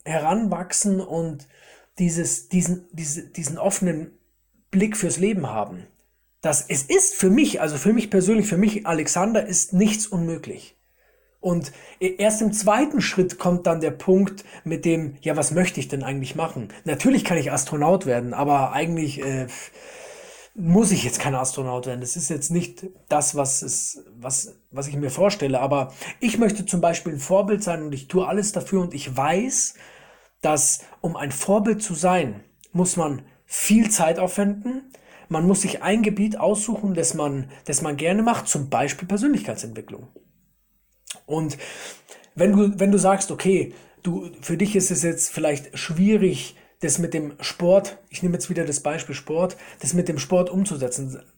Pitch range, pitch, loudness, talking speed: 150-195 Hz, 175 Hz, -22 LUFS, 165 wpm